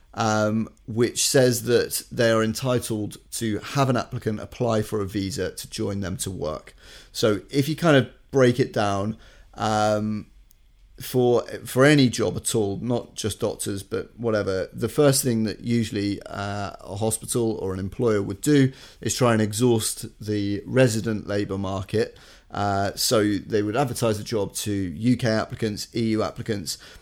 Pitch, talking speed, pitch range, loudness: 110 Hz, 160 wpm, 100-120 Hz, -24 LUFS